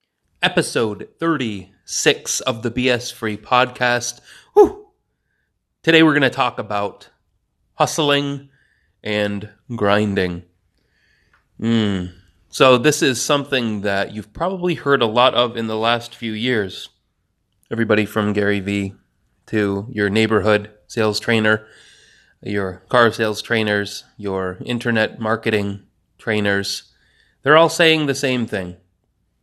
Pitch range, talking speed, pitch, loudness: 100-125 Hz, 115 wpm, 110 Hz, -19 LUFS